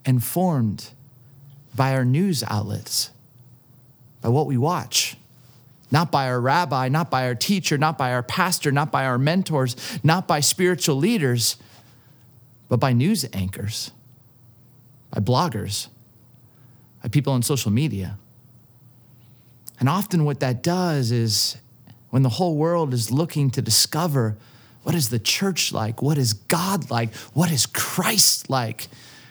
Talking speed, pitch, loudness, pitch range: 135 wpm, 125 Hz, -21 LUFS, 120-150 Hz